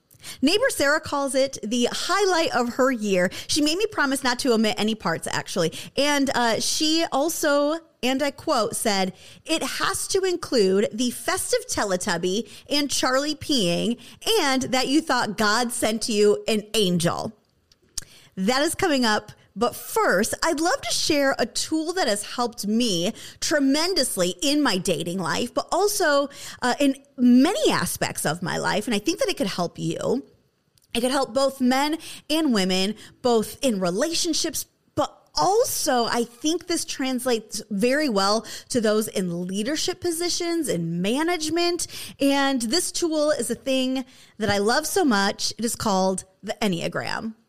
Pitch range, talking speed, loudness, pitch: 215-305 Hz, 160 wpm, -23 LUFS, 260 Hz